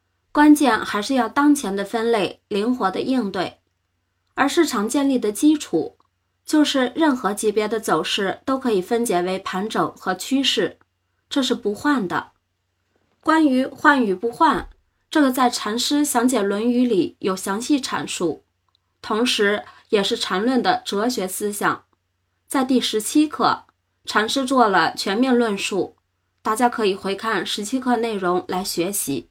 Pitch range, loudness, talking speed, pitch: 205-270 Hz, -20 LUFS, 220 characters per minute, 235 Hz